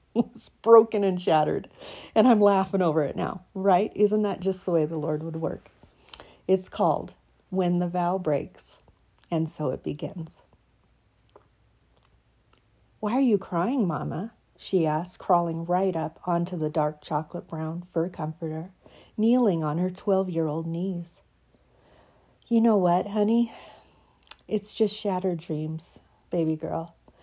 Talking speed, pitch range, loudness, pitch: 140 wpm, 160-200 Hz, -26 LUFS, 180 Hz